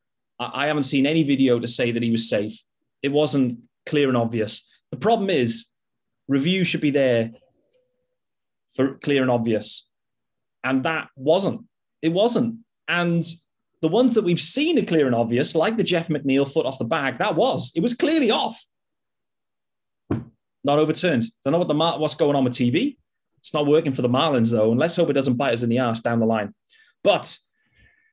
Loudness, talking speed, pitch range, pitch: -22 LUFS, 190 wpm, 120-170 Hz, 145 Hz